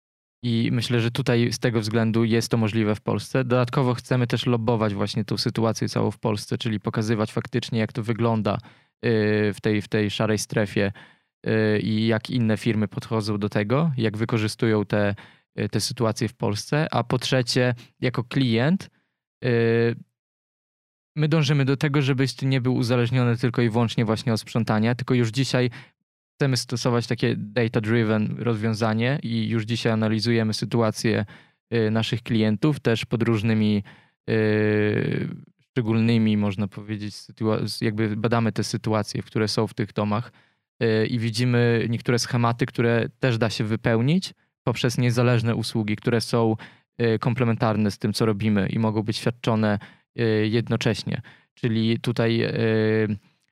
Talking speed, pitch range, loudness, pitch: 145 wpm, 110-125 Hz, -23 LUFS, 115 Hz